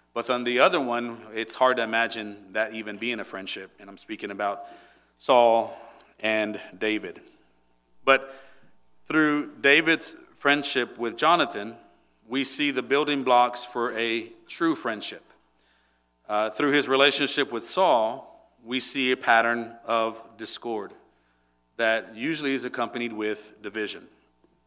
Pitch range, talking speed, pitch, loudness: 110-135 Hz, 130 wpm, 115 Hz, -25 LUFS